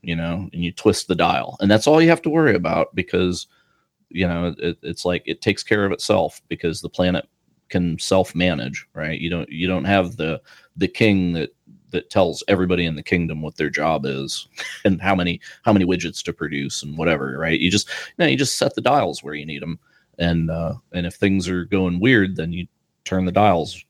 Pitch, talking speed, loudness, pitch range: 90 Hz, 225 wpm, -21 LUFS, 85-95 Hz